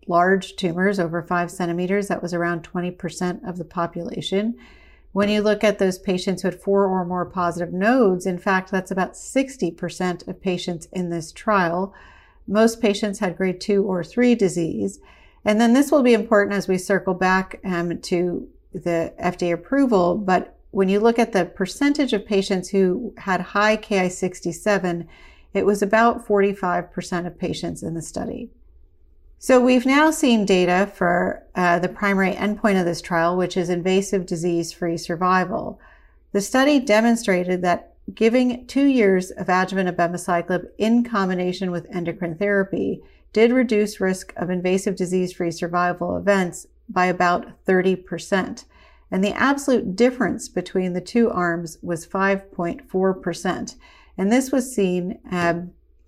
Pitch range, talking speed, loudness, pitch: 175-210 Hz, 150 wpm, -21 LUFS, 185 Hz